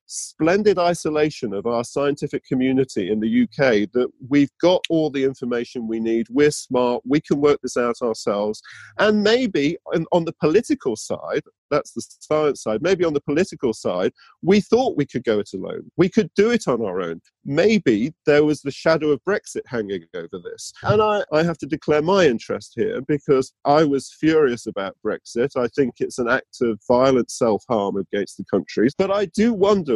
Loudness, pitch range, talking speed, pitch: -21 LUFS, 130-190 Hz, 190 wpm, 150 Hz